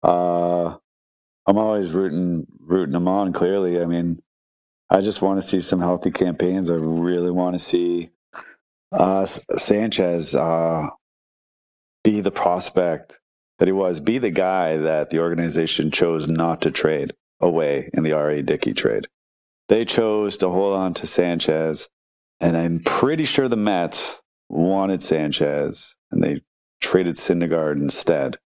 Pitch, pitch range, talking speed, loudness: 85 Hz, 80-95 Hz, 145 wpm, -21 LUFS